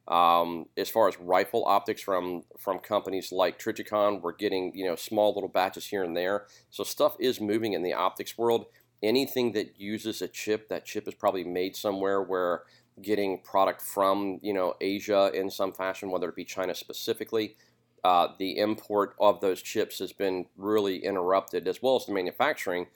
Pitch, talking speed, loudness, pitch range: 100 Hz, 185 wpm, -29 LUFS, 95-110 Hz